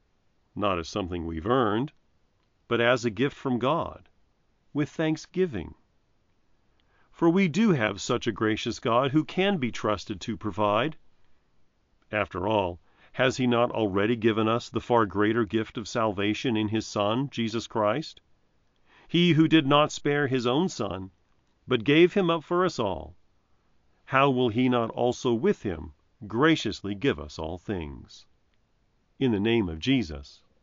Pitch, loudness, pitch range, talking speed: 115 Hz, -26 LUFS, 105-135 Hz, 155 wpm